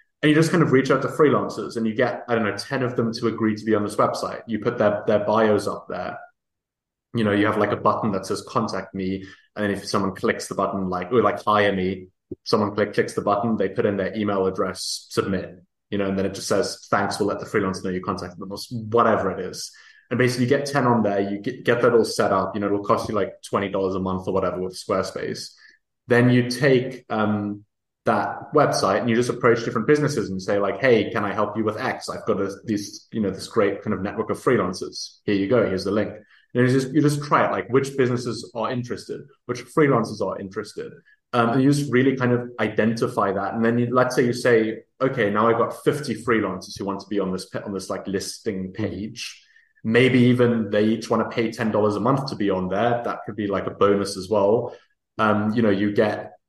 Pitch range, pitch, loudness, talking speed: 100-120 Hz, 110 Hz, -22 LUFS, 245 wpm